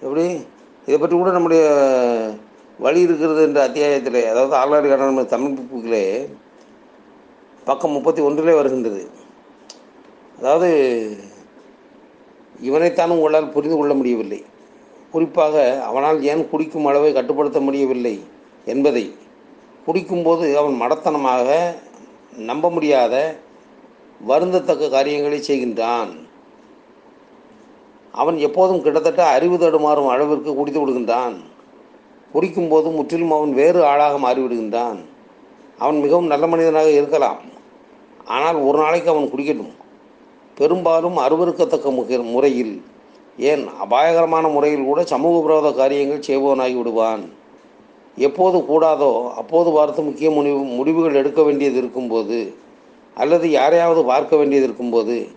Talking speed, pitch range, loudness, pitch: 100 wpm, 130-160 Hz, -17 LUFS, 145 Hz